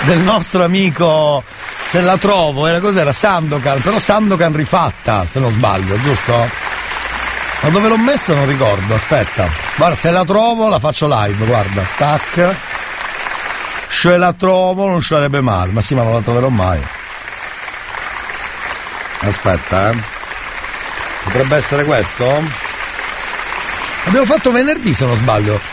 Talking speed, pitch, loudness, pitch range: 130 wpm, 150 Hz, -14 LUFS, 115-185 Hz